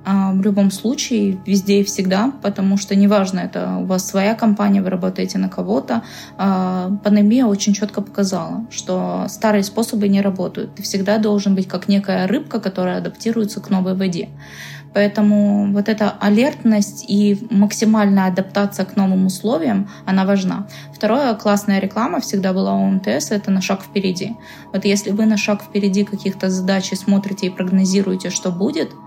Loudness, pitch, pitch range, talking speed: -18 LUFS, 200 Hz, 190-210 Hz, 155 wpm